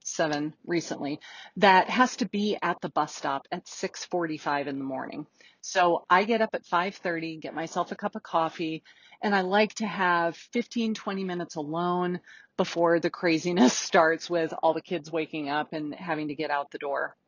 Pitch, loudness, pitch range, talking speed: 175 Hz, -27 LUFS, 160-190 Hz, 185 wpm